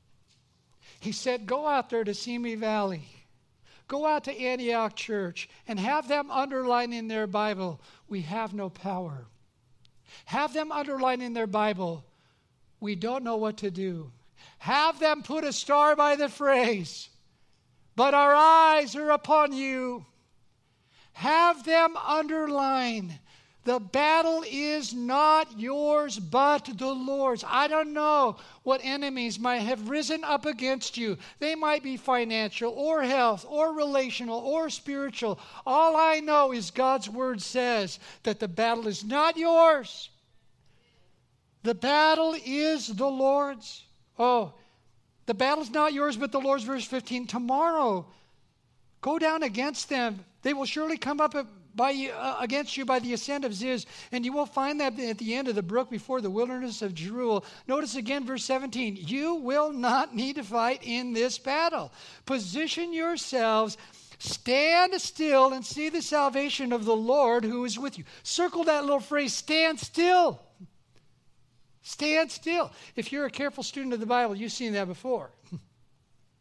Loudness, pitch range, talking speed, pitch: -27 LUFS, 220-290 Hz, 150 wpm, 255 Hz